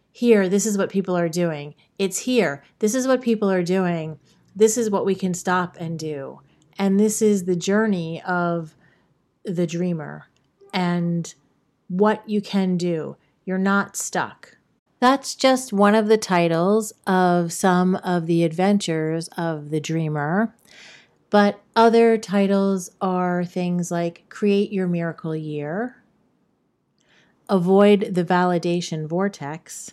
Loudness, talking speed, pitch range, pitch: -21 LUFS, 135 wpm, 170-205 Hz, 185 Hz